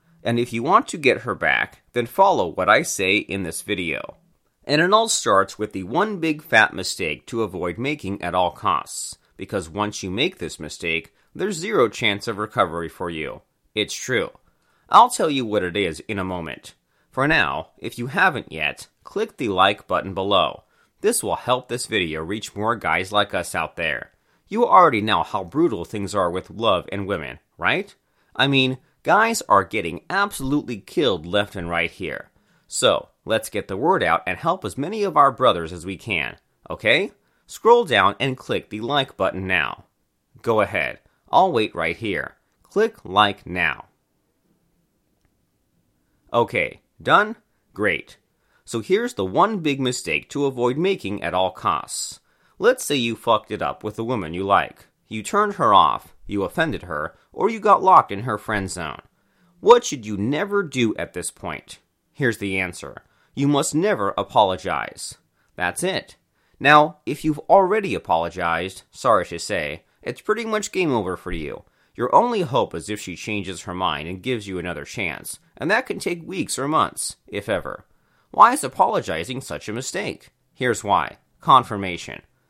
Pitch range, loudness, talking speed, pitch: 95-150 Hz, -21 LUFS, 175 wpm, 110 Hz